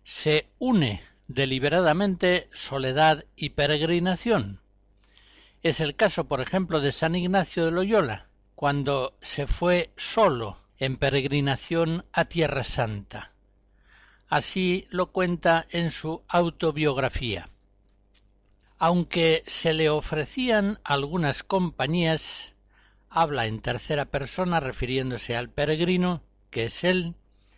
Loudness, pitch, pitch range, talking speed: -25 LUFS, 155 Hz, 125-175 Hz, 100 wpm